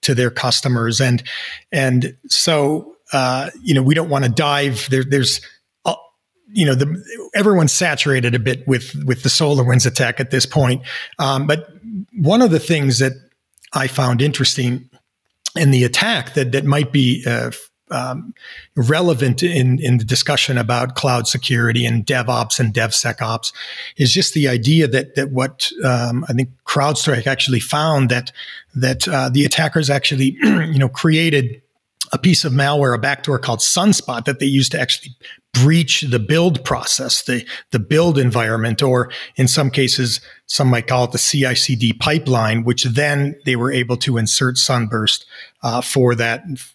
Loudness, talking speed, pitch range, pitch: -16 LUFS, 165 wpm, 125-145 Hz, 135 Hz